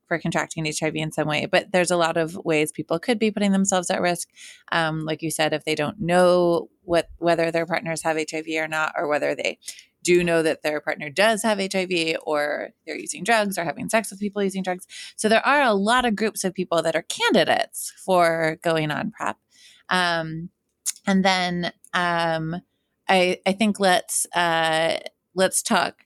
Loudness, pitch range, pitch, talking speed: -22 LUFS, 160-190 Hz, 170 Hz, 195 wpm